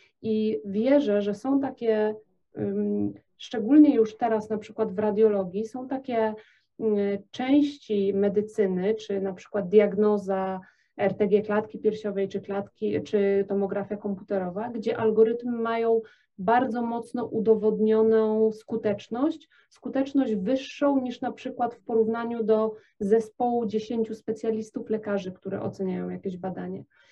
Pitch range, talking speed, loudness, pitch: 200-235 Hz, 115 wpm, -26 LUFS, 220 Hz